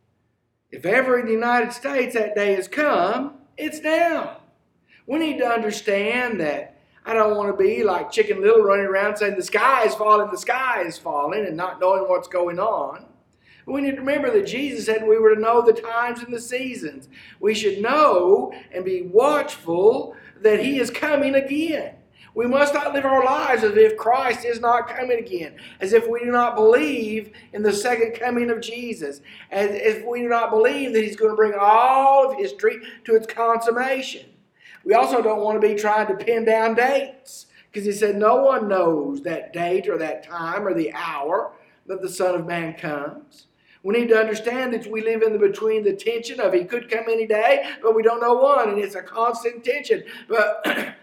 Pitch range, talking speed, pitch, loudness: 210-270 Hz, 200 wpm, 230 Hz, -20 LUFS